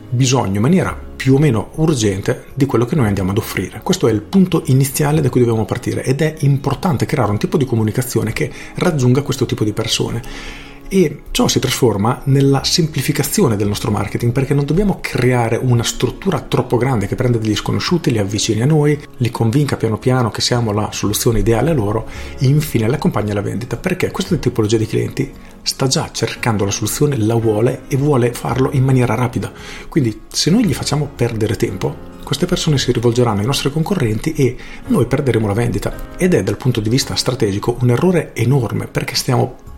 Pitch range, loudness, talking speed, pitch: 110-145 Hz, -16 LUFS, 195 wpm, 125 Hz